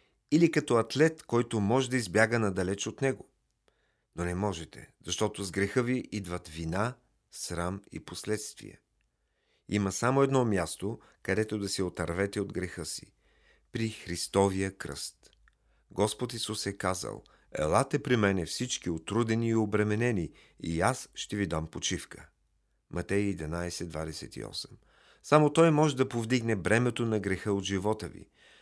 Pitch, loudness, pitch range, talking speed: 105 Hz, -30 LUFS, 90-120 Hz, 140 wpm